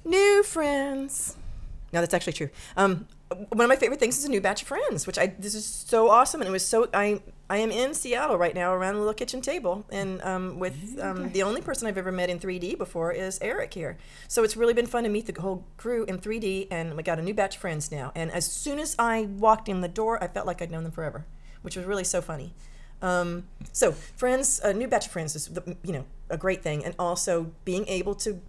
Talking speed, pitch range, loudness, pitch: 245 wpm, 175-230 Hz, -27 LUFS, 190 Hz